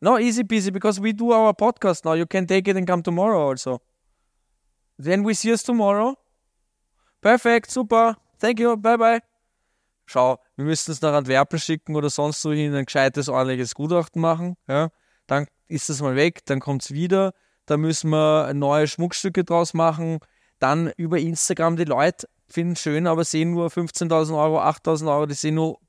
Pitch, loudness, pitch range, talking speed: 165 Hz, -21 LUFS, 150-195 Hz, 180 wpm